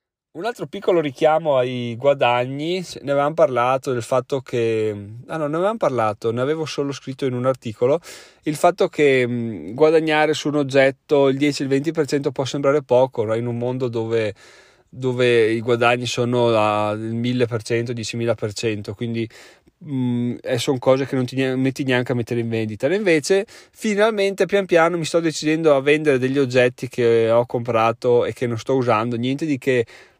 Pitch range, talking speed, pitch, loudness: 120-150 Hz, 175 wpm, 130 Hz, -20 LUFS